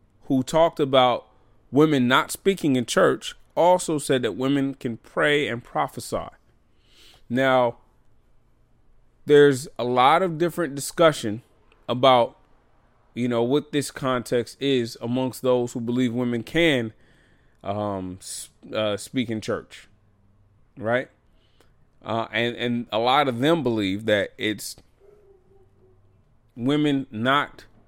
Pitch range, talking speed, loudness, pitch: 110-140 Hz, 115 wpm, -23 LUFS, 120 Hz